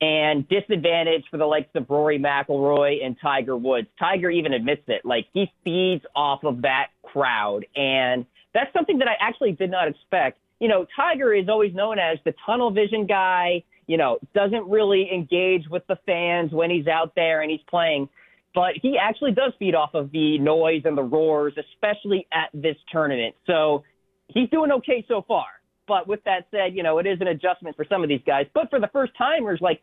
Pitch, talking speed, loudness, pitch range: 175 Hz, 200 wpm, -22 LUFS, 150-200 Hz